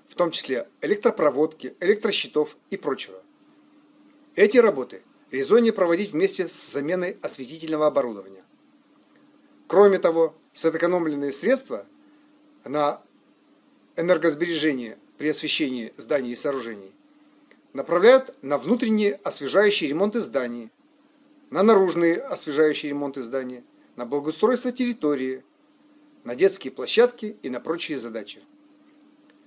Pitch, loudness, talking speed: 195 Hz, -23 LUFS, 100 wpm